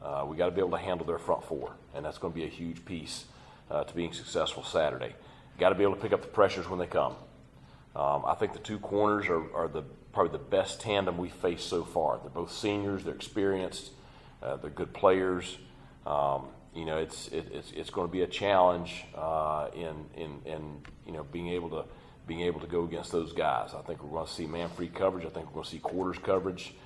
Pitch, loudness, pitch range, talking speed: 85 Hz, -32 LUFS, 80-95 Hz, 240 wpm